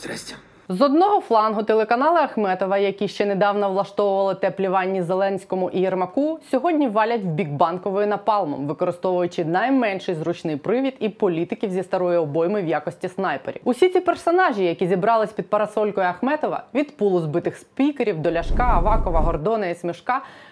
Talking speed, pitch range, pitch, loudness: 145 wpm, 180-235 Hz, 200 Hz, -21 LUFS